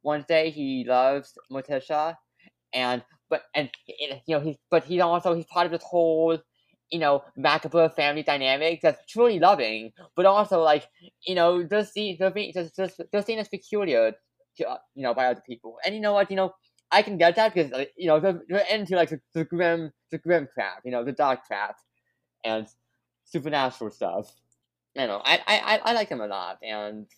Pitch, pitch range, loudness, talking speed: 160 Hz, 135-180 Hz, -25 LUFS, 195 wpm